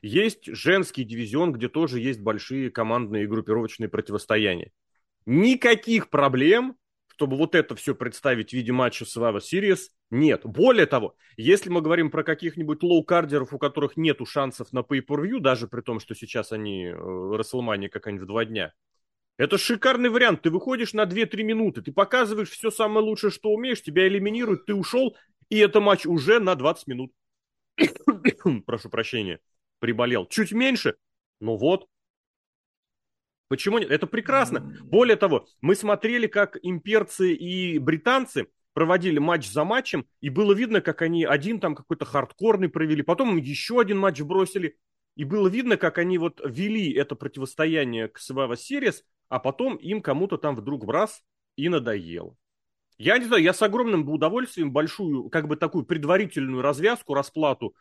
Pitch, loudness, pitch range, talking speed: 165 Hz, -24 LUFS, 130-210 Hz, 160 wpm